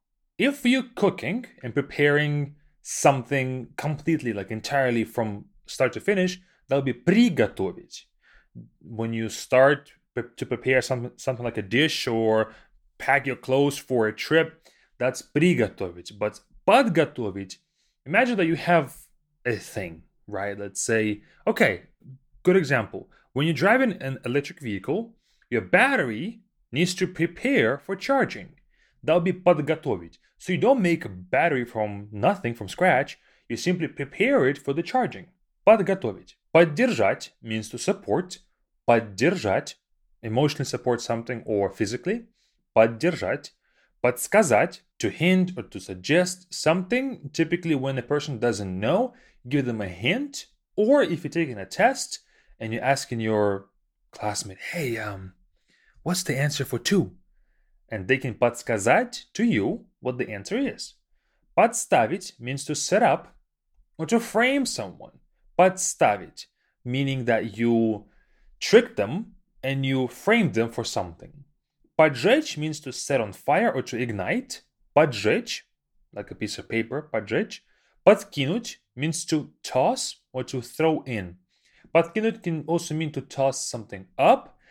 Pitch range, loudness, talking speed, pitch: 115-175 Hz, -24 LUFS, 135 wpm, 140 Hz